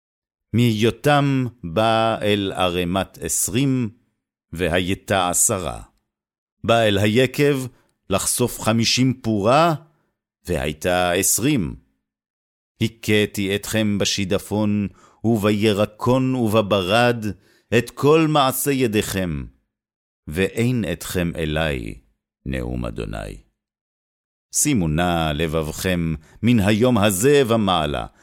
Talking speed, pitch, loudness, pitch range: 80 wpm, 105 Hz, -20 LUFS, 90-120 Hz